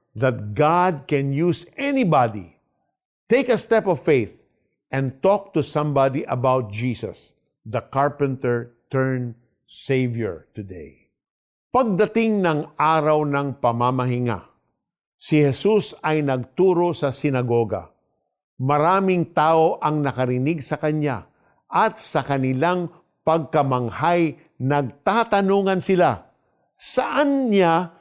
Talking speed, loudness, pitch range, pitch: 100 wpm, -21 LUFS, 130-180 Hz, 150 Hz